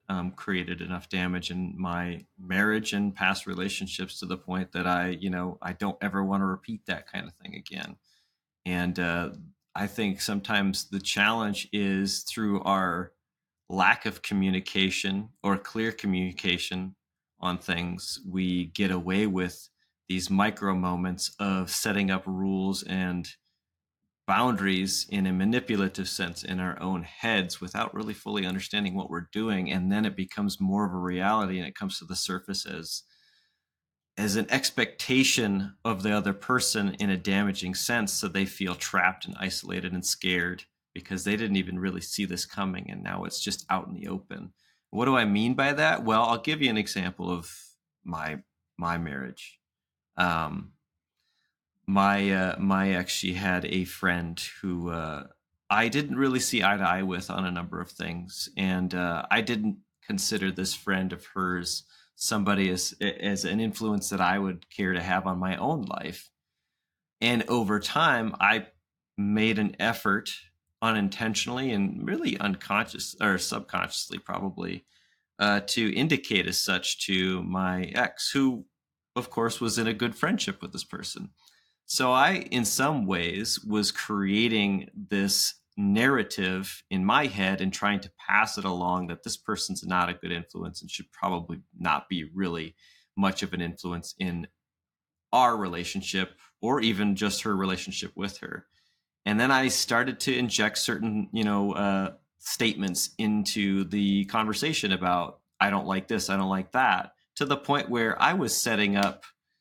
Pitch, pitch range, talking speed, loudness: 95 Hz, 90-105 Hz, 165 wpm, -28 LUFS